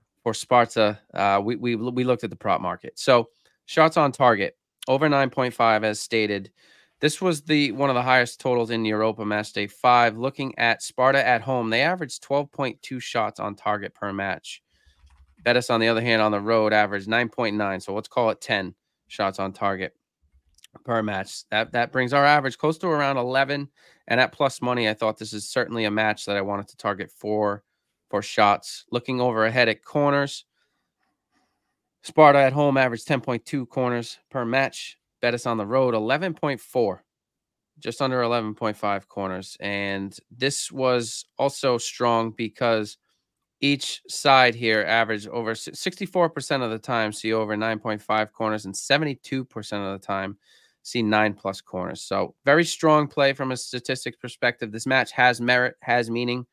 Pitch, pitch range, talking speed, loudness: 120 Hz, 105-135 Hz, 165 wpm, -23 LUFS